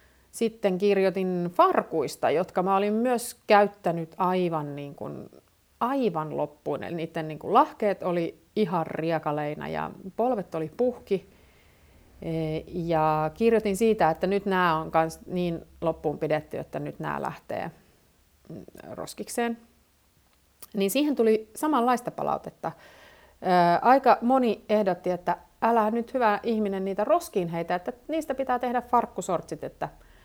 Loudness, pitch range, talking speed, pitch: -26 LUFS, 160-225 Hz, 125 wpm, 185 Hz